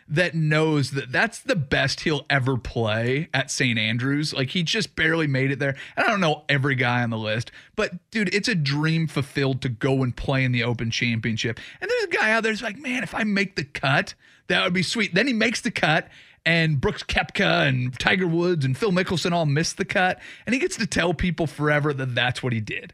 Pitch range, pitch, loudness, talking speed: 130-185 Hz, 150 Hz, -23 LUFS, 235 wpm